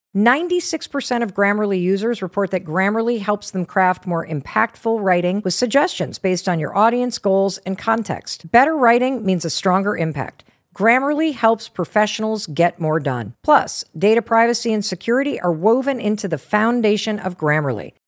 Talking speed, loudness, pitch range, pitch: 155 wpm, -19 LUFS, 180-230 Hz, 205 Hz